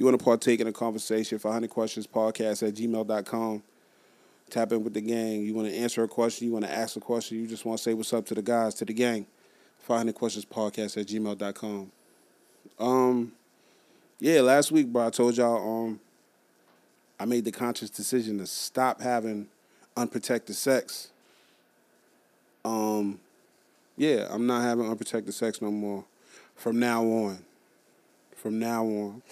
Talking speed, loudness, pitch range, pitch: 165 wpm, -28 LUFS, 105-120 Hz, 115 Hz